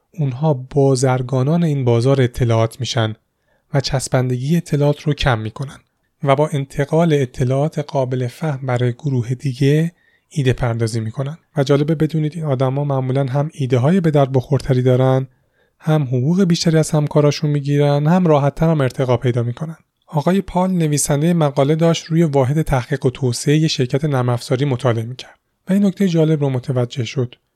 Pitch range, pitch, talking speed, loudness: 130-155 Hz, 140 Hz, 150 wpm, -17 LUFS